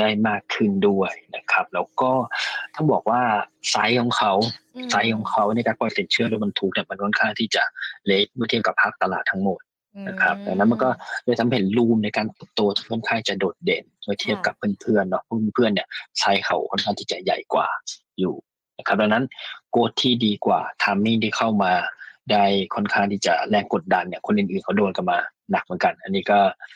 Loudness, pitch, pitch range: -22 LUFS, 110 Hz, 105-120 Hz